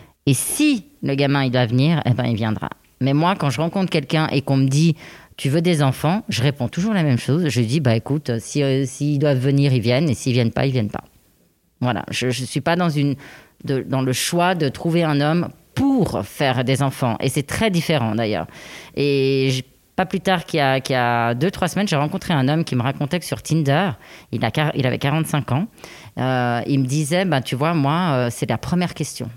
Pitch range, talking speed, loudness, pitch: 125-160 Hz, 240 wpm, -20 LUFS, 140 Hz